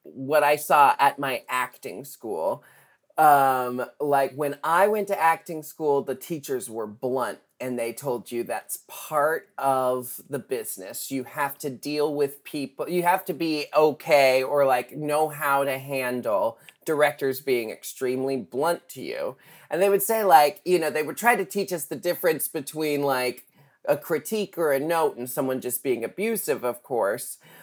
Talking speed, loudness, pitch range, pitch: 175 wpm, -25 LUFS, 130-165 Hz, 145 Hz